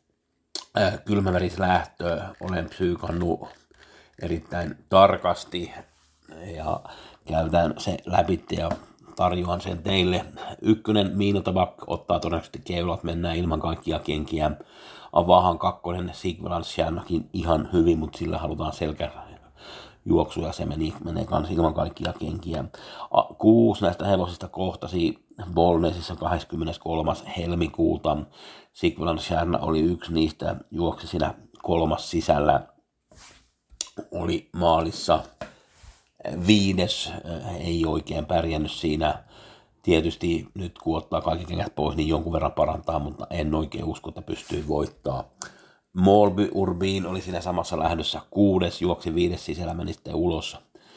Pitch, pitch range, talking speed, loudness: 85 Hz, 80-95 Hz, 110 wpm, -25 LUFS